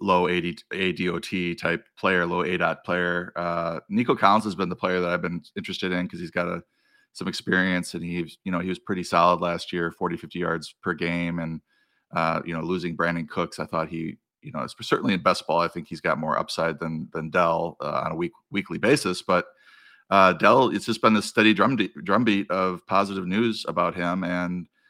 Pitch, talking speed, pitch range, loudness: 90 Hz, 220 wpm, 85-90 Hz, -25 LUFS